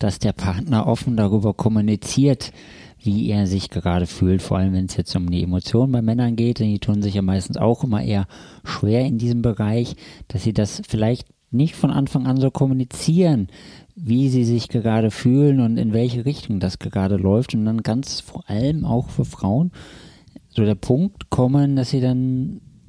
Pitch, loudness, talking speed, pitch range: 115 Hz, -20 LUFS, 190 wpm, 100-130 Hz